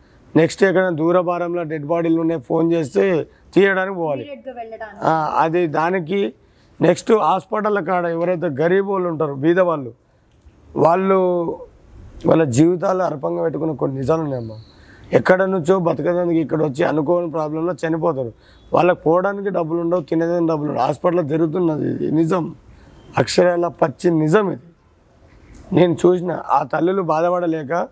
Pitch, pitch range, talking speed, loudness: 170 Hz, 160-180 Hz, 120 wpm, -18 LUFS